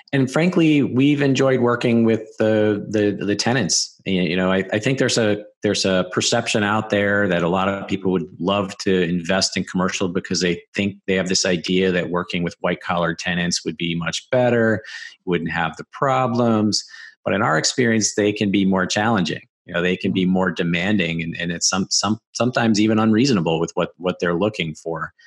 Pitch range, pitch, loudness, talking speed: 90-110 Hz, 100 Hz, -20 LUFS, 200 wpm